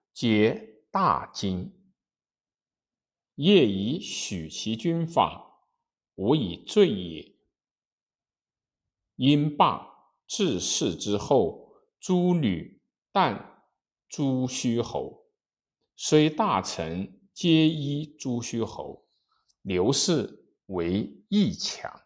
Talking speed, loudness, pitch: 105 characters per minute, -26 LUFS, 150 Hz